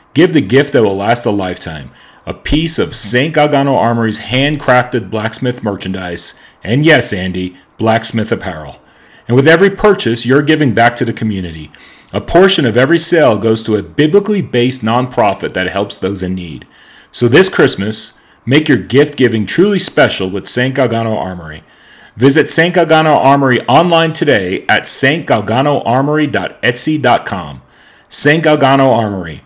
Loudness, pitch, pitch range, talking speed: -11 LUFS, 120 Hz, 105-150 Hz, 145 wpm